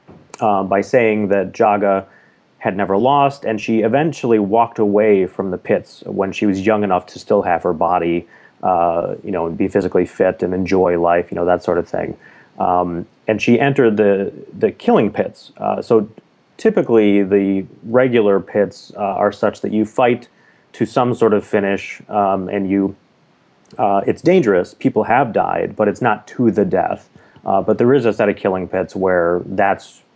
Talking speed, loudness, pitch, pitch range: 185 wpm, -17 LUFS, 100 Hz, 95-110 Hz